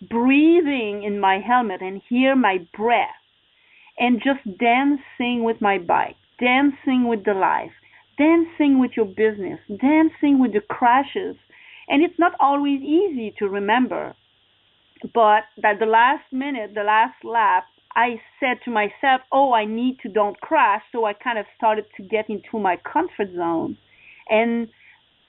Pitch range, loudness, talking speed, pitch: 215-275 Hz, -20 LUFS, 150 wpm, 240 Hz